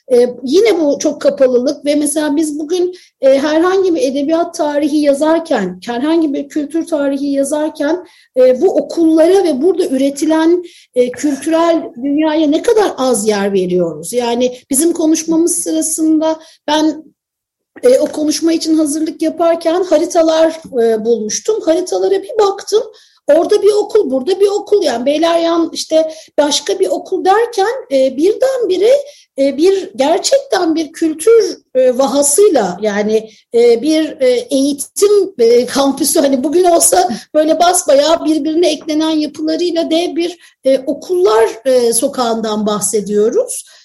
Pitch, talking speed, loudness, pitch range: 315 Hz, 120 wpm, -13 LUFS, 280-355 Hz